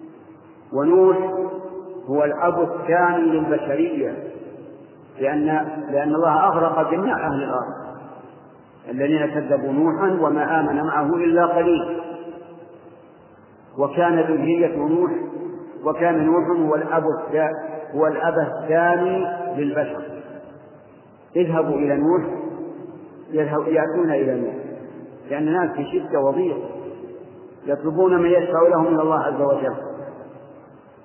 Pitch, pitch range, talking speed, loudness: 165 Hz, 150-175 Hz, 95 wpm, -20 LUFS